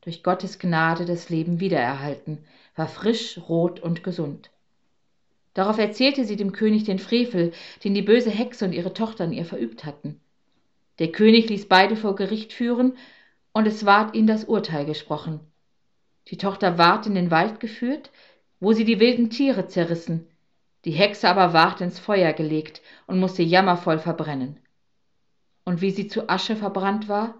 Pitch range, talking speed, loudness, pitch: 165-220 Hz, 160 wpm, -22 LUFS, 185 Hz